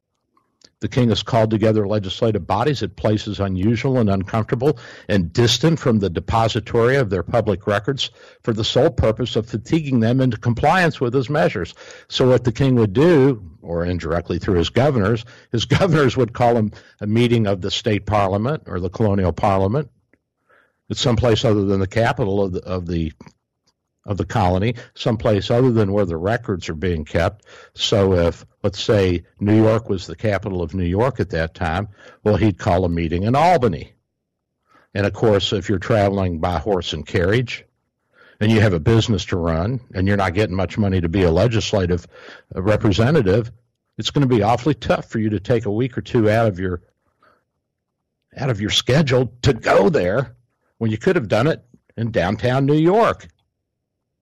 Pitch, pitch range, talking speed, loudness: 110 Hz, 95-120 Hz, 185 wpm, -19 LUFS